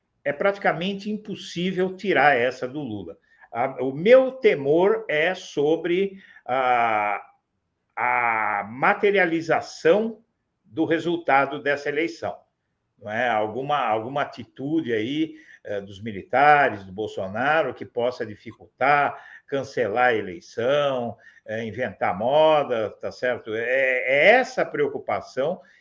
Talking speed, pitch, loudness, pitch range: 110 wpm, 160 Hz, -23 LUFS, 125-205 Hz